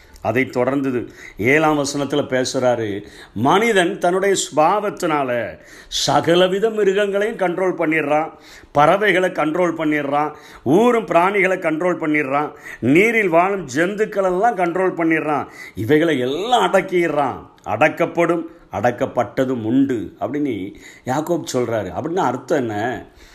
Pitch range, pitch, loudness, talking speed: 140-185 Hz, 160 Hz, -18 LUFS, 95 wpm